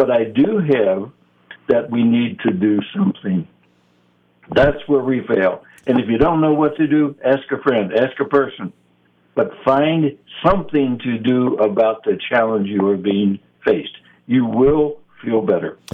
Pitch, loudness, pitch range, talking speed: 125 Hz, -18 LUFS, 100-140 Hz, 165 wpm